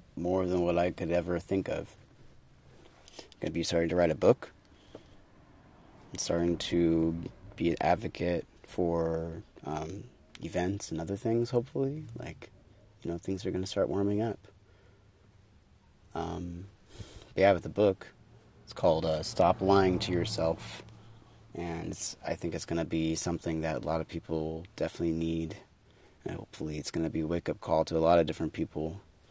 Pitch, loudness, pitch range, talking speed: 90 Hz, -31 LUFS, 80-100 Hz, 160 wpm